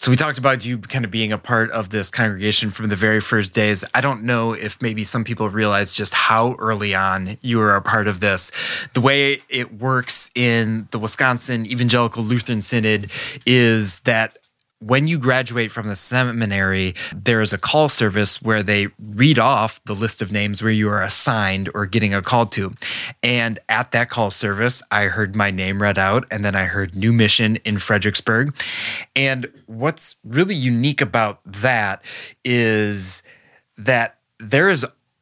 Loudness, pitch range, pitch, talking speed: -18 LUFS, 105-125 Hz, 110 Hz, 180 wpm